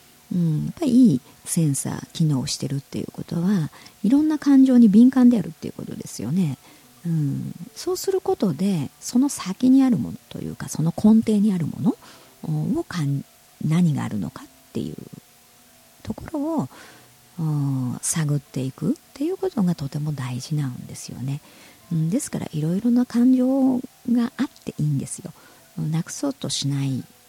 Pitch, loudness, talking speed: 175 Hz, -22 LUFS, 325 characters per minute